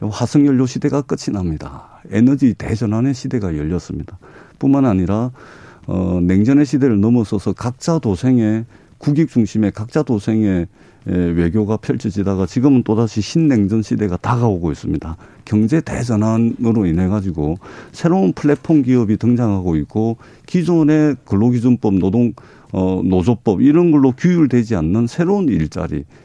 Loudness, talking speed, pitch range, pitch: -16 LUFS, 325 characters per minute, 100-135 Hz, 115 Hz